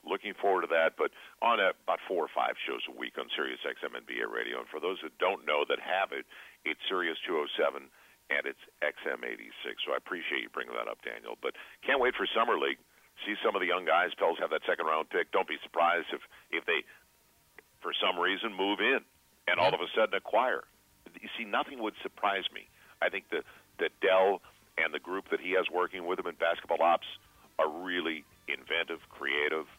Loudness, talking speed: -32 LUFS, 210 wpm